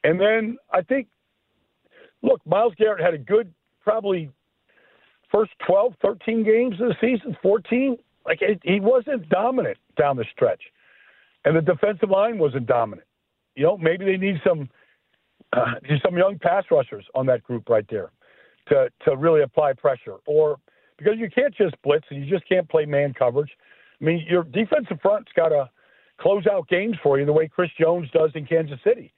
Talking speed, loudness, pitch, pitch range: 180 wpm, -22 LUFS, 200 Hz, 160-255 Hz